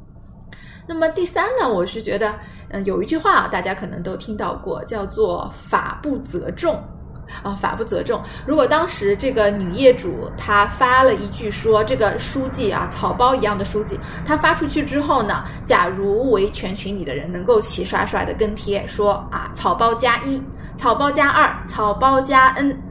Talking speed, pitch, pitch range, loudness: 255 characters per minute, 250 Hz, 205-285 Hz, -19 LUFS